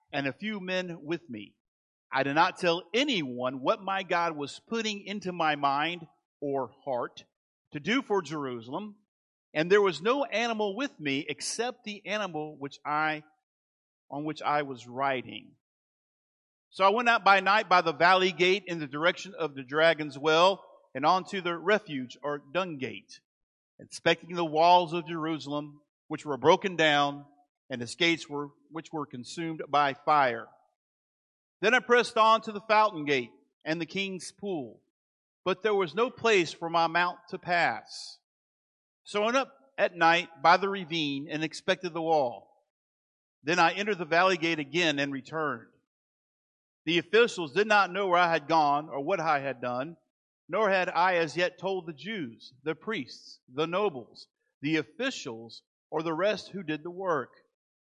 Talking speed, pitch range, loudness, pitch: 170 wpm, 145-195 Hz, -28 LUFS, 170 Hz